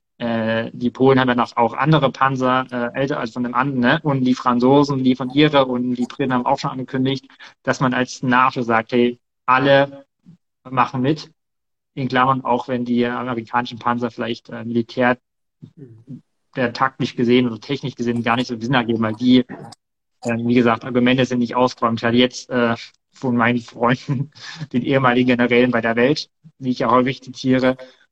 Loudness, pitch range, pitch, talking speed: -19 LUFS, 120-135 Hz, 125 Hz, 180 wpm